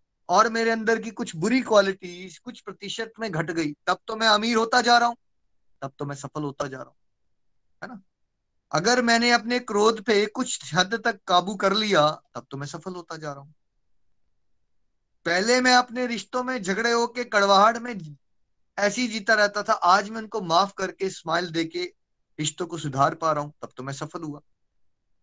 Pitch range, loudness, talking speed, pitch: 150-230 Hz, -23 LUFS, 190 wpm, 195 Hz